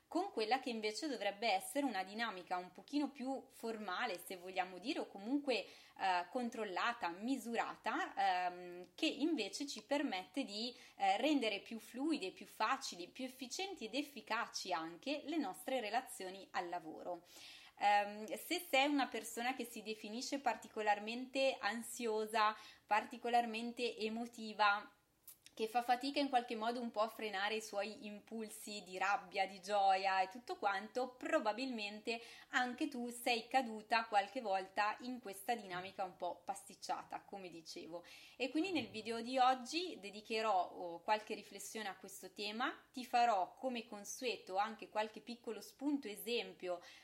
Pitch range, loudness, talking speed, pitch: 200-260 Hz, -40 LUFS, 140 wpm, 225 Hz